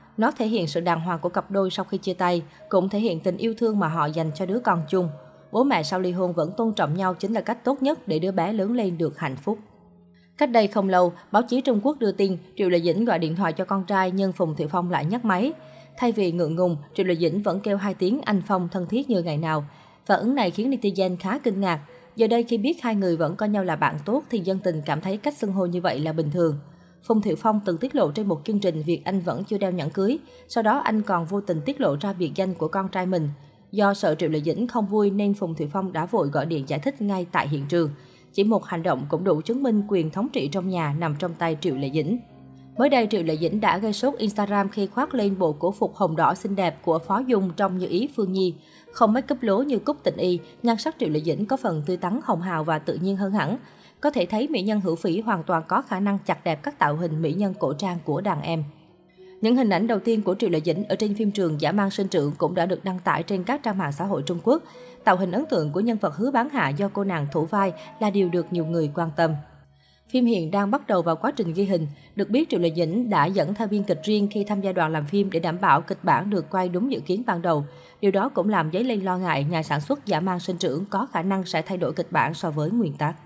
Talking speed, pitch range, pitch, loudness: 280 wpm, 170-215 Hz, 190 Hz, -24 LUFS